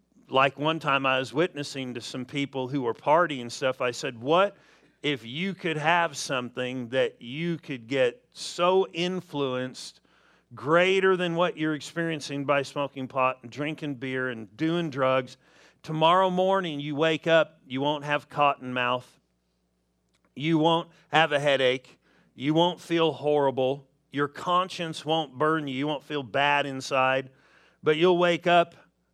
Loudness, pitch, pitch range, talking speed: -26 LUFS, 145 Hz, 130-165 Hz, 155 wpm